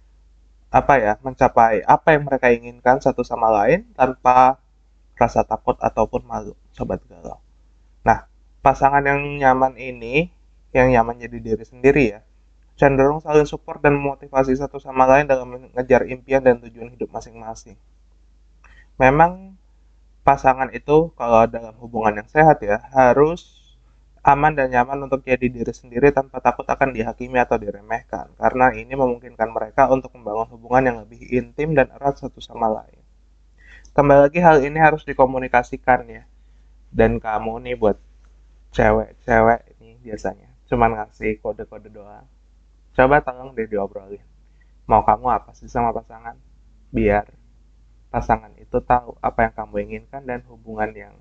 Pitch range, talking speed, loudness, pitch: 110-135 Hz, 140 wpm, -19 LUFS, 120 Hz